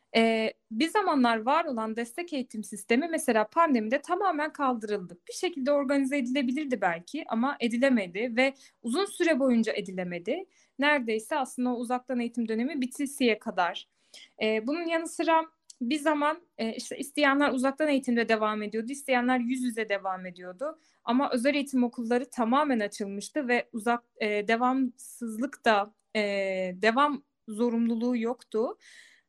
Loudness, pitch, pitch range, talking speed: -28 LUFS, 250 Hz, 225-285 Hz, 135 wpm